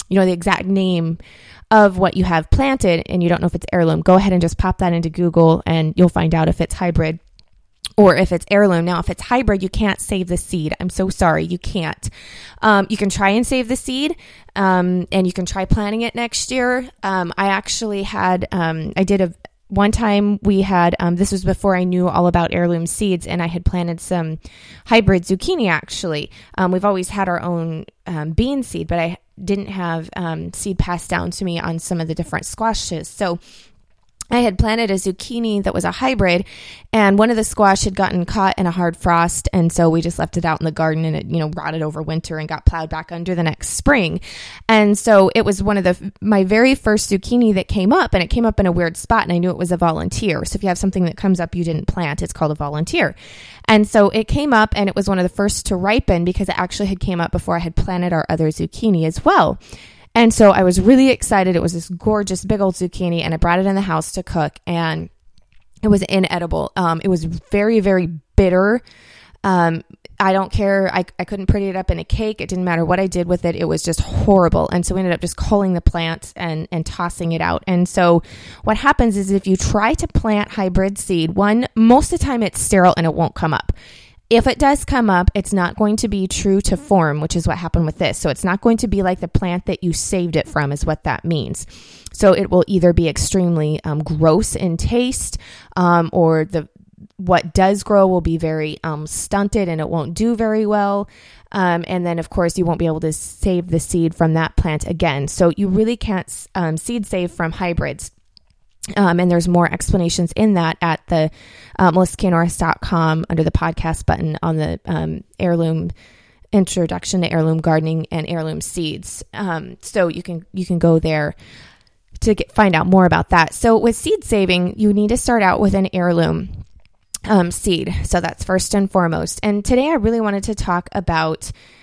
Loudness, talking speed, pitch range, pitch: -17 LUFS, 225 wpm, 165-200 Hz, 180 Hz